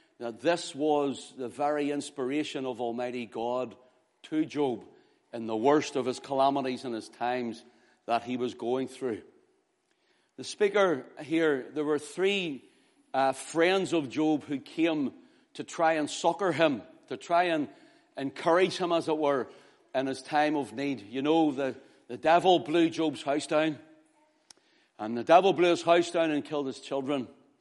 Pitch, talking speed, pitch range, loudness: 150 Hz, 165 wpm, 135-175 Hz, -29 LUFS